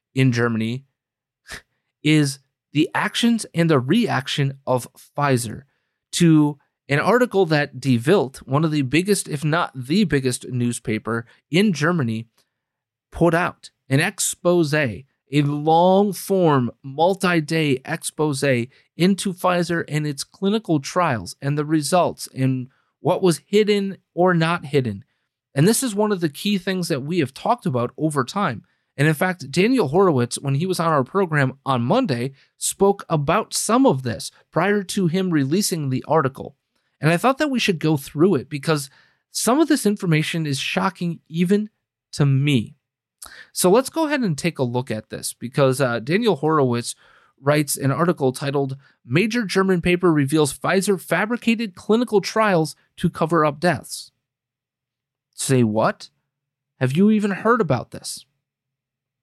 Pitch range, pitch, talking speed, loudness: 135-185 Hz, 155 Hz, 150 wpm, -20 LUFS